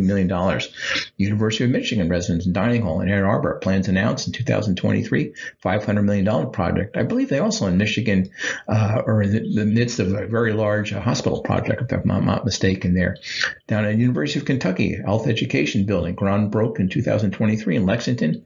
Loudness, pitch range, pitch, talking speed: -21 LUFS, 95-110 Hz, 105 Hz, 185 wpm